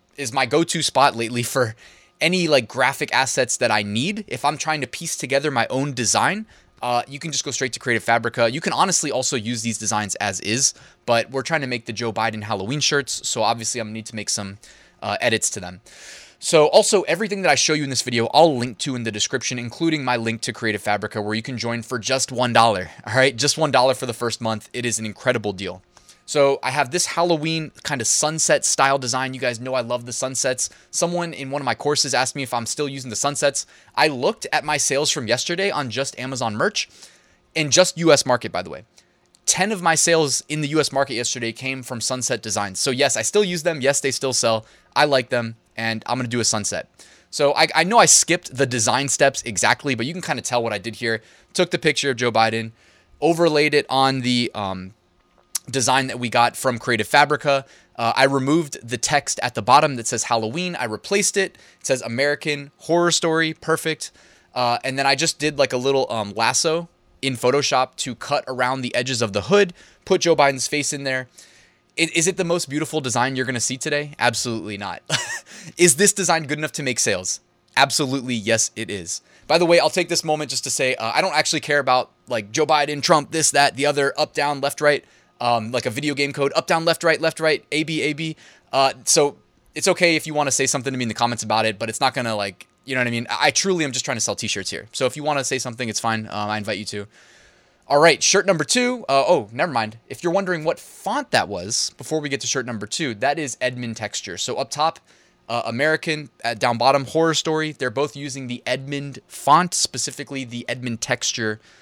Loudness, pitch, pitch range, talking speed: -20 LUFS, 135 Hz, 115-155 Hz, 235 wpm